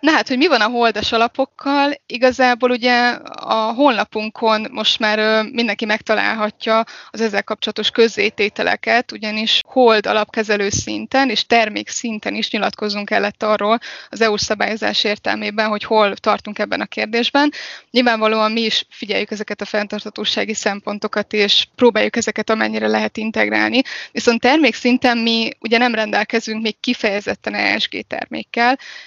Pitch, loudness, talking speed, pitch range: 220 Hz, -17 LUFS, 135 wpm, 210-240 Hz